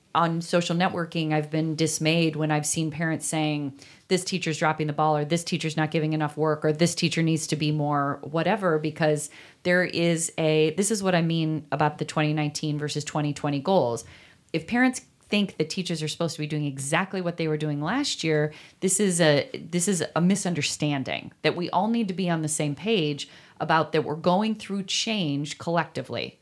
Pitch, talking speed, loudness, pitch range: 155 Hz, 200 wpm, -25 LUFS, 150-175 Hz